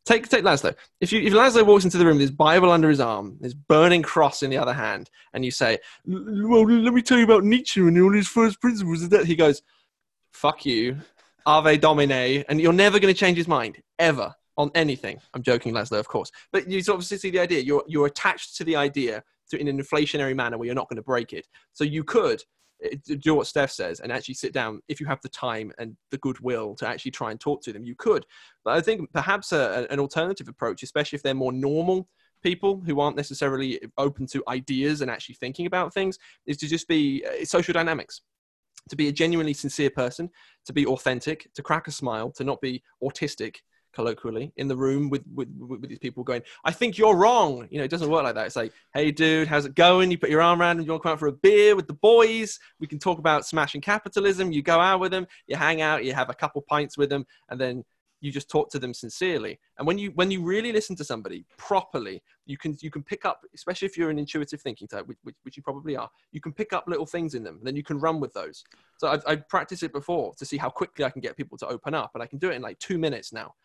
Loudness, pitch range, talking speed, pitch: -23 LUFS, 135-180 Hz, 250 wpm, 150 Hz